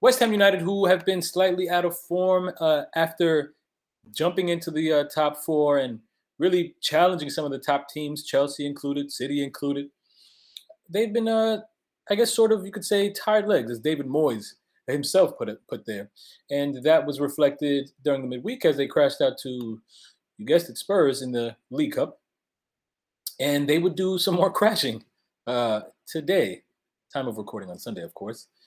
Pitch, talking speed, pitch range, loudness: 155 Hz, 180 wpm, 140-185 Hz, -24 LUFS